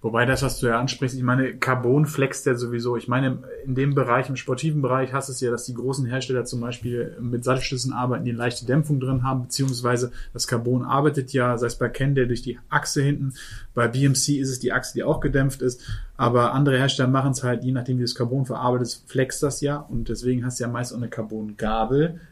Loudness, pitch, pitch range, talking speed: -24 LUFS, 130 Hz, 120-135 Hz, 230 wpm